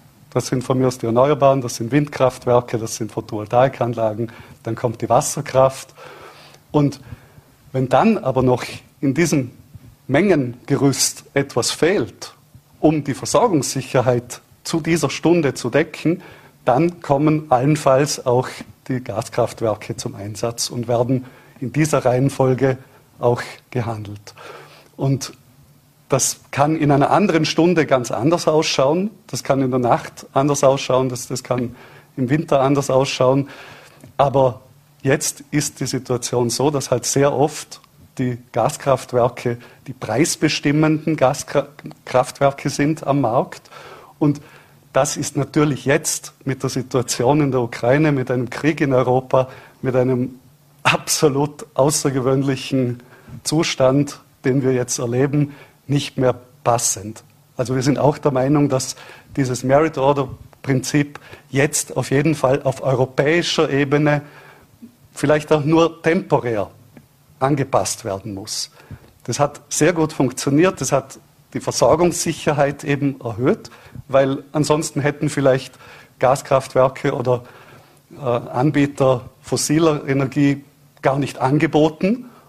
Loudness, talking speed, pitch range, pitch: -19 LUFS, 120 wpm, 125-145 Hz, 135 Hz